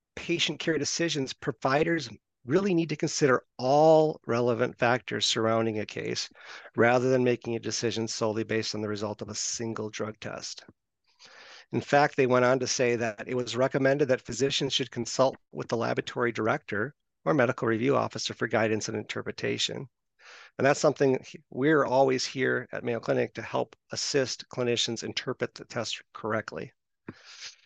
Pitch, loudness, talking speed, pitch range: 125 Hz, -28 LUFS, 160 wpm, 115-145 Hz